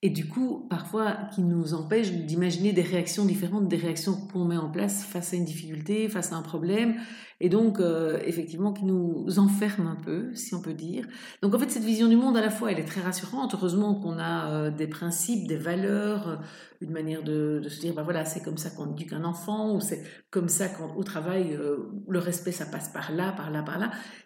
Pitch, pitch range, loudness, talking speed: 180 Hz, 165-205 Hz, -28 LUFS, 230 wpm